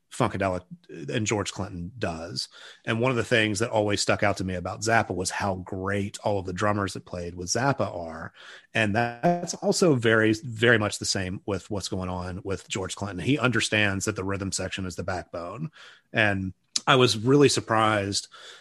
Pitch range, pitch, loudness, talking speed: 95-115 Hz, 105 Hz, -26 LUFS, 190 wpm